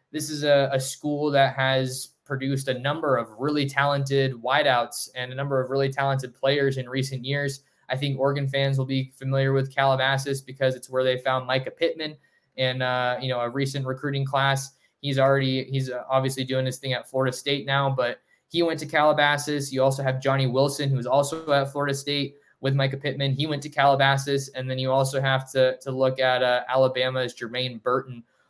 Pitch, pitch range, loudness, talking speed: 135 Hz, 130-140 Hz, -24 LUFS, 200 wpm